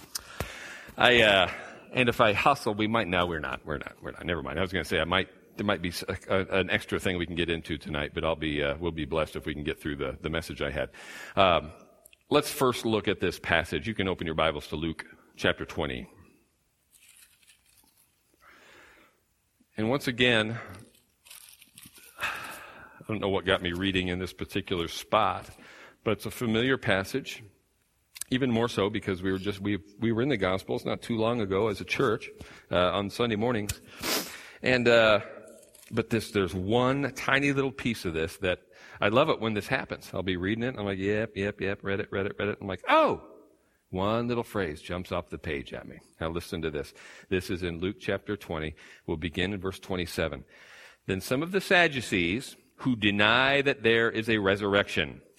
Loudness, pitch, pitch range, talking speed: -28 LUFS, 100 Hz, 90-115 Hz, 200 wpm